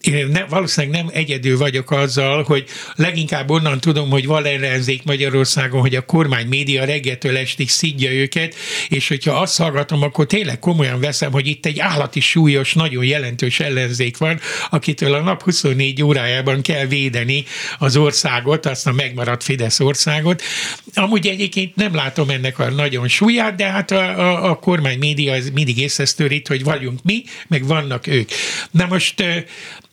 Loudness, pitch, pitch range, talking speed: -17 LUFS, 145 Hz, 135-165 Hz, 160 wpm